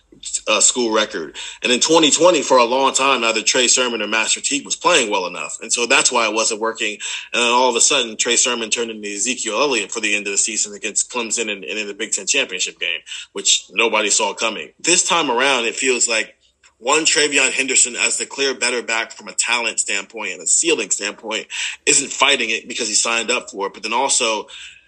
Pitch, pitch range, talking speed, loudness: 120 Hz, 110-135 Hz, 225 wpm, -16 LUFS